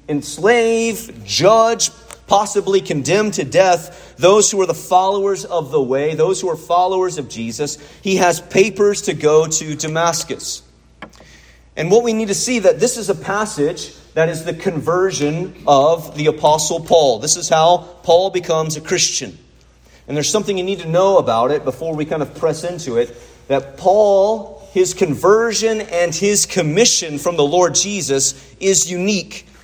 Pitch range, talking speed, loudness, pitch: 150-195 Hz, 165 wpm, -16 LUFS, 175 Hz